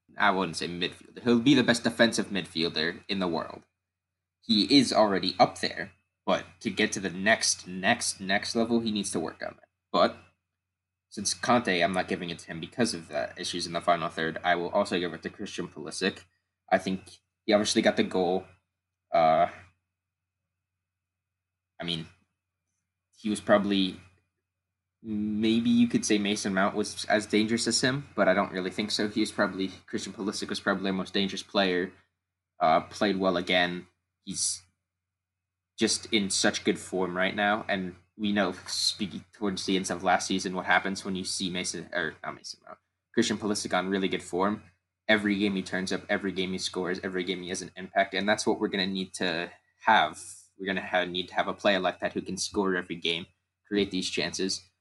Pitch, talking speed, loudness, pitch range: 95 Hz, 195 wpm, -28 LUFS, 90-100 Hz